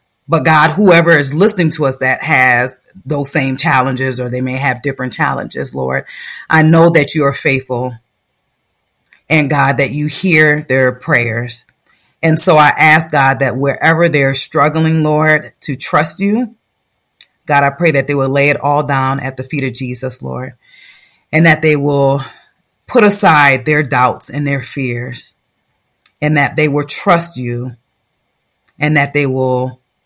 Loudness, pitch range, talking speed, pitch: -12 LUFS, 130-155 Hz, 165 wpm, 140 Hz